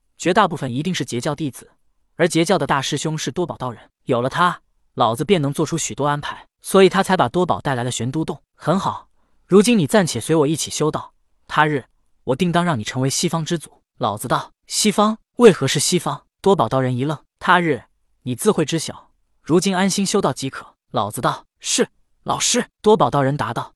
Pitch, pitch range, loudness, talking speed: 155 Hz, 135-185 Hz, -19 LUFS, 300 characters per minute